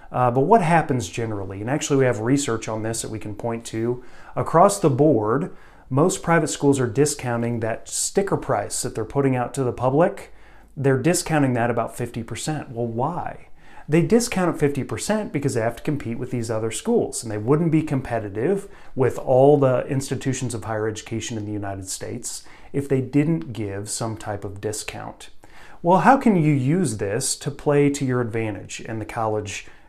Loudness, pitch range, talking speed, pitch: -22 LUFS, 115-145 Hz, 185 wpm, 125 Hz